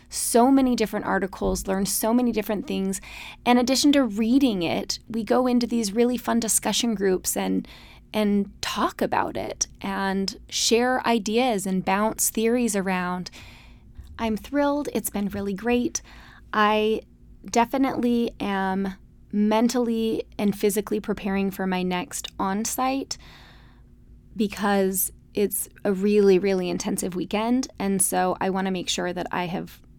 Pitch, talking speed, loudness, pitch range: 210 Hz, 135 wpm, -24 LUFS, 195-235 Hz